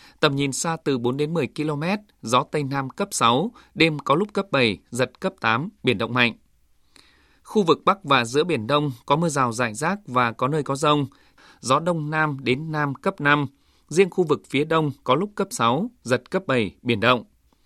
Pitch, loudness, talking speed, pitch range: 145 Hz, -22 LUFS, 210 wpm, 125-170 Hz